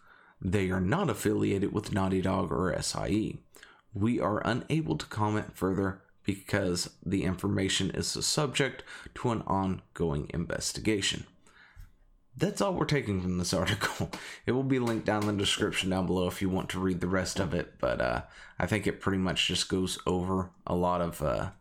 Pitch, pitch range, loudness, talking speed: 95 Hz, 95-105 Hz, -30 LUFS, 185 wpm